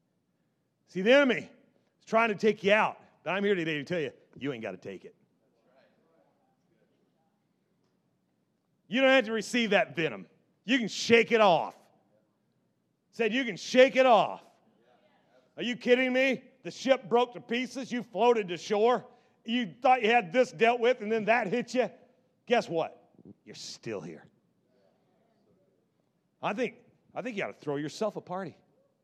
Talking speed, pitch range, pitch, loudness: 165 wpm, 195-245 Hz, 230 Hz, -28 LUFS